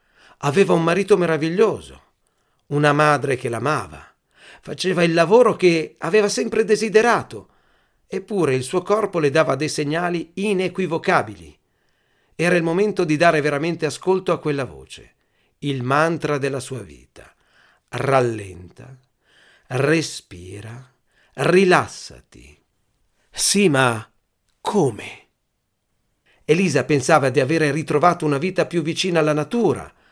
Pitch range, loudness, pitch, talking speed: 130-175 Hz, -19 LUFS, 155 Hz, 110 wpm